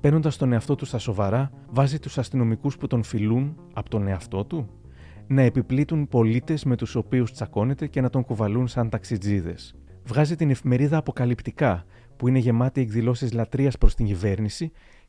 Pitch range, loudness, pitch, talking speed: 110-135 Hz, -24 LUFS, 125 Hz, 165 wpm